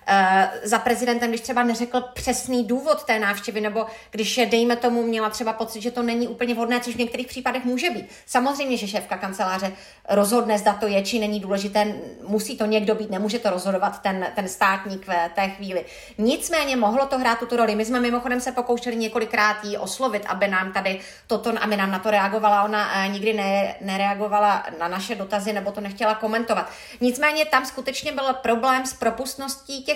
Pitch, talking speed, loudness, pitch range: 225 Hz, 190 wpm, -23 LUFS, 205-245 Hz